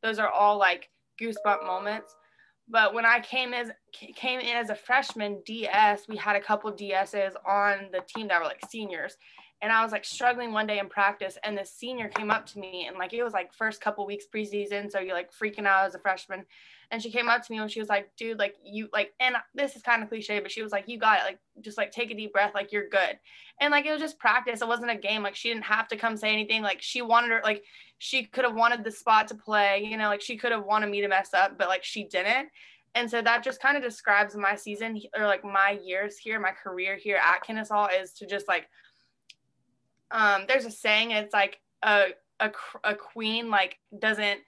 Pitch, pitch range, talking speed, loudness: 215 Hz, 200-230 Hz, 245 wpm, -27 LUFS